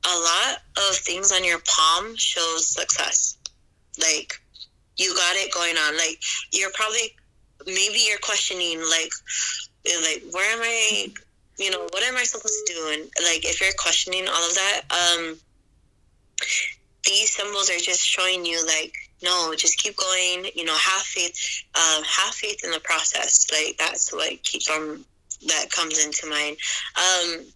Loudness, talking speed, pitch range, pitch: -21 LUFS, 160 wpm, 165-195 Hz, 180 Hz